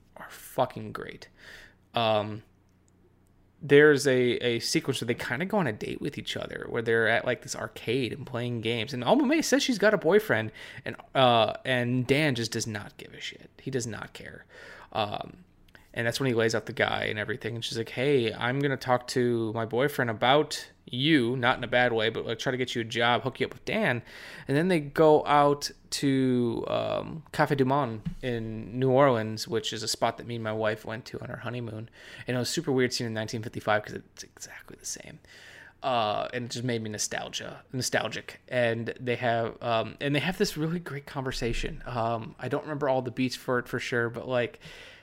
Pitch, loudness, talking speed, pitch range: 125 Hz, -28 LUFS, 220 wpm, 115-140 Hz